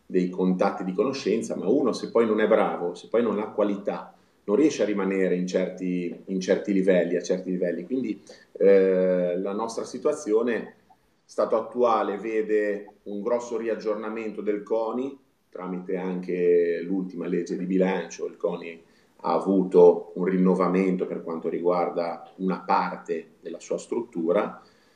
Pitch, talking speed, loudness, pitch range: 95 Hz, 145 wpm, -25 LUFS, 90-110 Hz